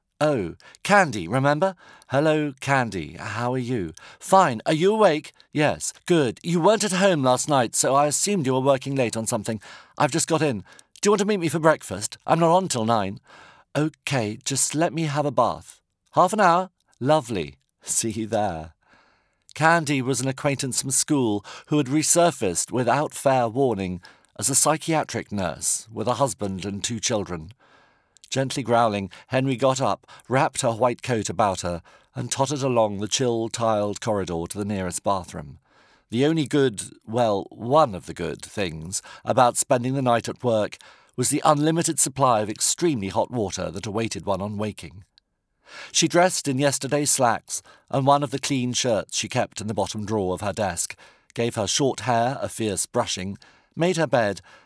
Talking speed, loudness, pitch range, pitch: 180 wpm, -23 LUFS, 105-150 Hz, 130 Hz